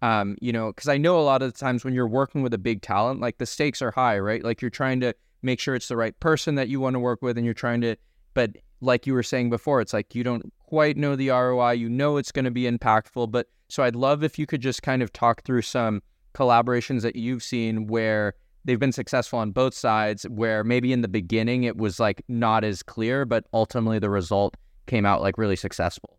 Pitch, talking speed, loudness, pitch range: 120 Hz, 250 wpm, -24 LUFS, 110-130 Hz